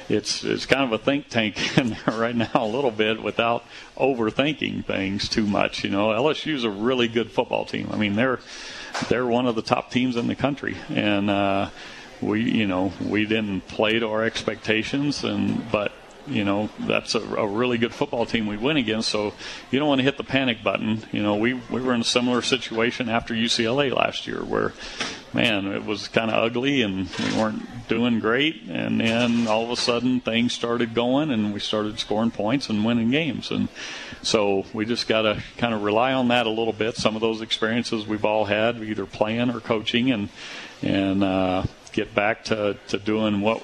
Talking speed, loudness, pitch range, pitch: 205 wpm, -23 LUFS, 105-120 Hz, 115 Hz